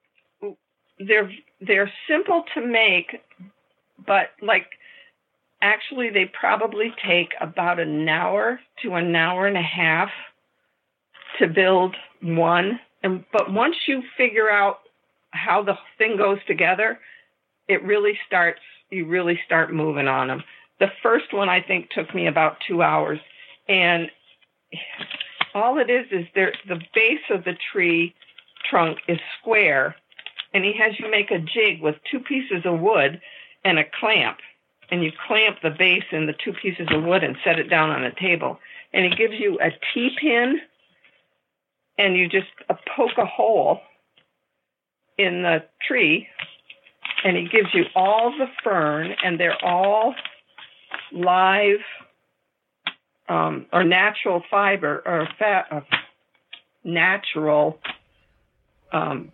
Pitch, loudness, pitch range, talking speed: 195 Hz, -21 LUFS, 175-225 Hz, 140 wpm